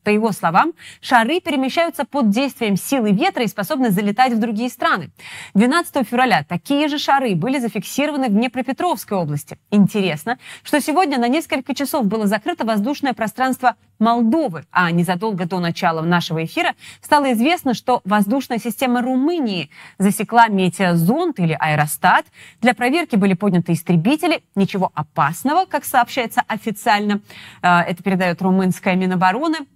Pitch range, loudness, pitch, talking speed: 185-270 Hz, -18 LUFS, 225 Hz, 135 wpm